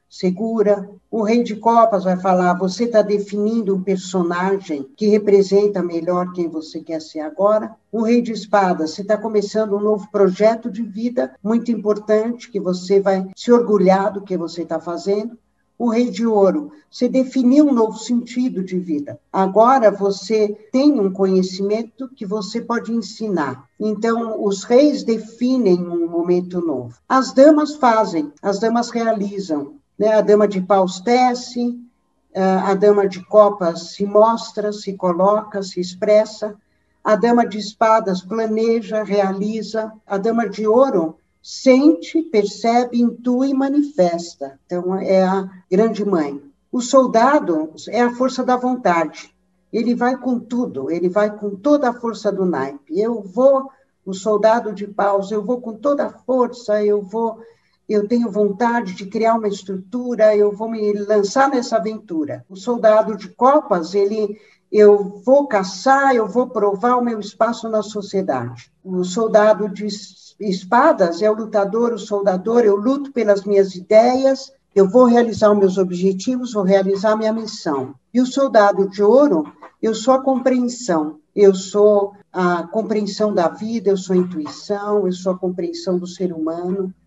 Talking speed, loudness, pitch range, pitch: 155 wpm, -18 LUFS, 190-235 Hz, 210 Hz